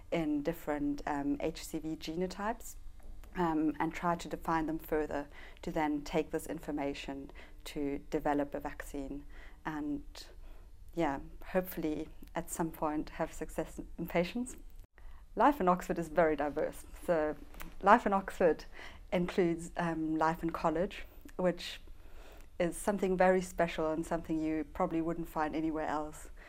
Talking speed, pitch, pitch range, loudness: 135 wpm, 160 Hz, 150-175 Hz, -35 LUFS